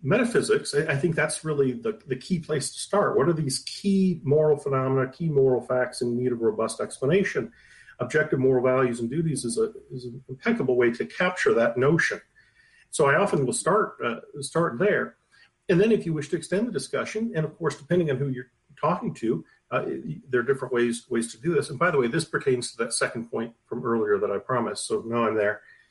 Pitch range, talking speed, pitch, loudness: 125-180 Hz, 220 wpm, 145 Hz, -25 LUFS